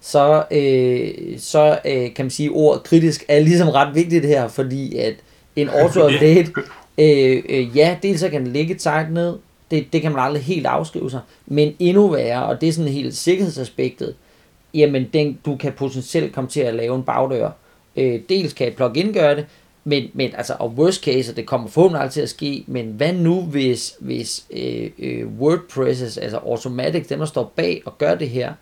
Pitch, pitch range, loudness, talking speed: 145 Hz, 130-160 Hz, -18 LUFS, 195 wpm